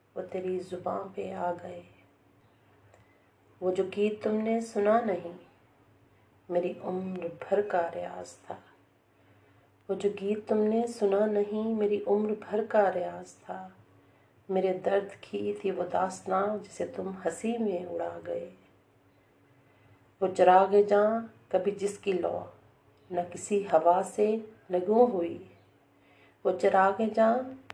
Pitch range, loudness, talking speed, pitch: 140-205 Hz, -29 LUFS, 130 wpm, 185 Hz